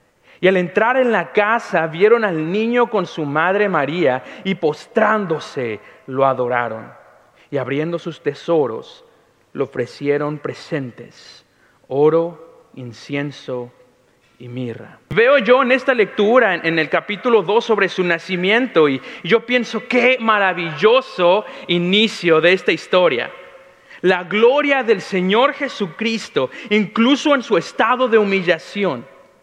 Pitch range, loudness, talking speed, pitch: 155-230 Hz, -17 LUFS, 120 wpm, 190 Hz